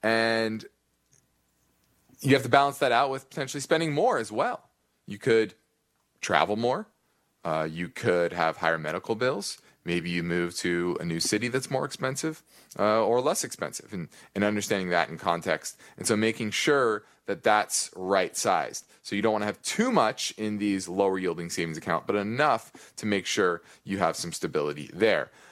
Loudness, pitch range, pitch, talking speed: -27 LUFS, 85-115 Hz, 100 Hz, 180 wpm